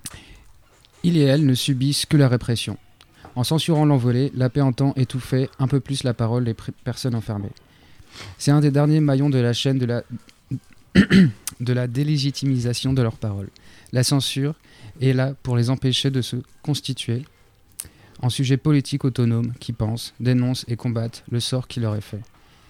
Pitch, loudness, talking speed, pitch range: 125 Hz, -21 LUFS, 170 wpm, 115-135 Hz